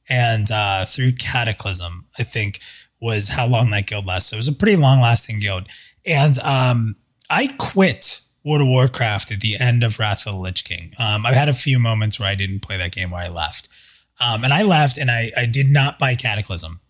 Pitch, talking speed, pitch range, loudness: 115 Hz, 220 wpm, 100-130 Hz, -17 LUFS